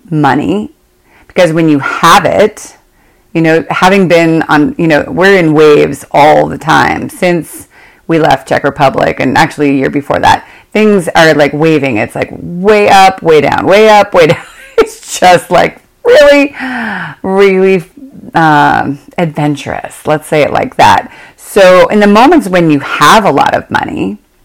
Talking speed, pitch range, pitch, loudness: 165 wpm, 150-210 Hz, 175 Hz, -8 LUFS